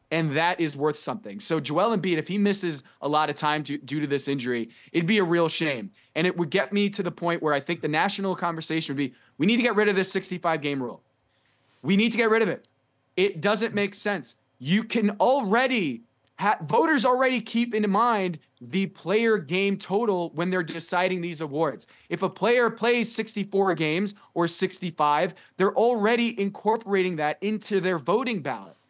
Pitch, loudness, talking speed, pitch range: 185 Hz, -25 LUFS, 200 wpm, 155-205 Hz